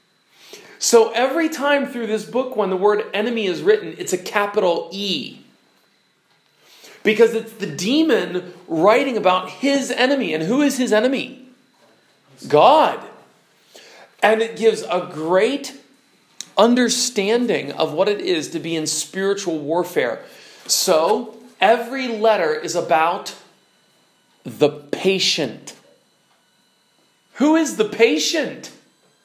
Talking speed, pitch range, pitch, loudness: 115 wpm, 180-250 Hz, 215 Hz, -19 LUFS